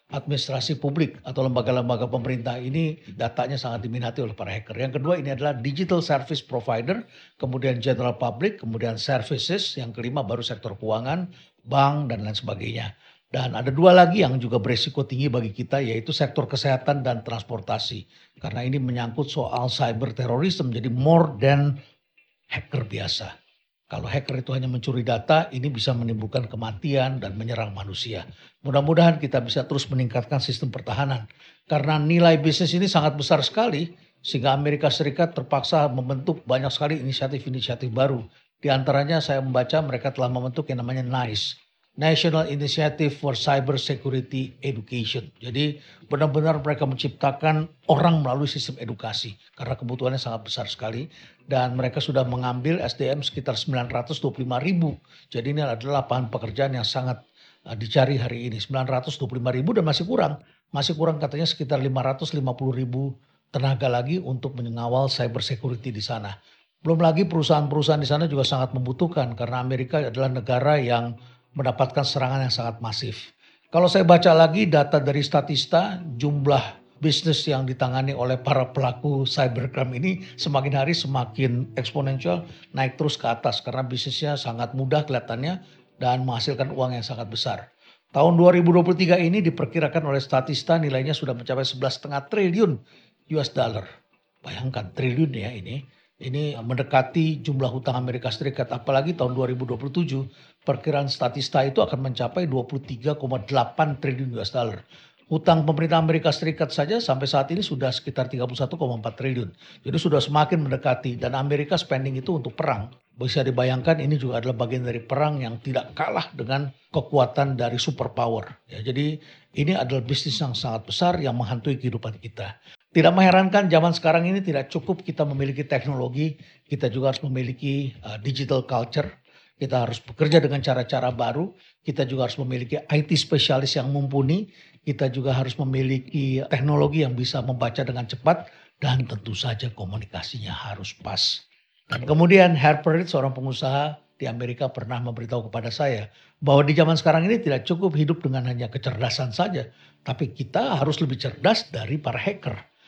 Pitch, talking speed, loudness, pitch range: 135 Hz, 145 wpm, -24 LUFS, 125-150 Hz